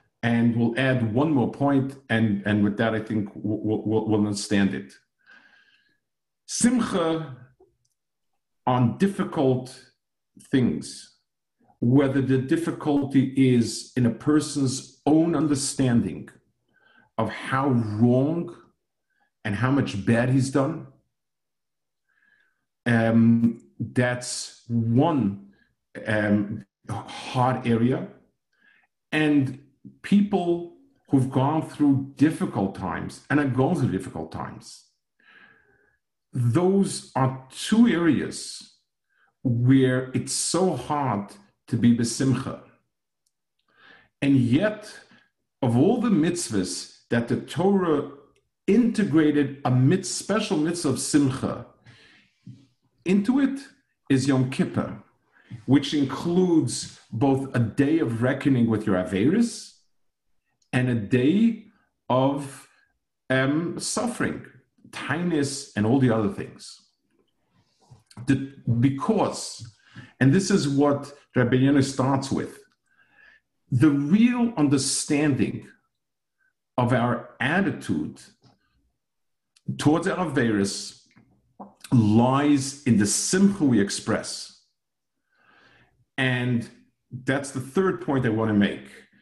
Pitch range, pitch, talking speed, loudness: 120-165 Hz, 135 Hz, 95 wpm, -23 LUFS